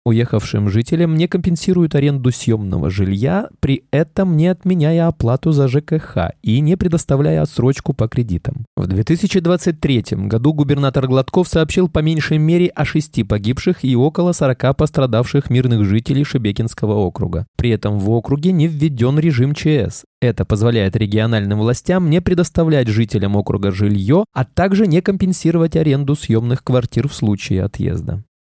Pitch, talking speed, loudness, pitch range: 135 Hz, 140 wpm, -16 LUFS, 115-165 Hz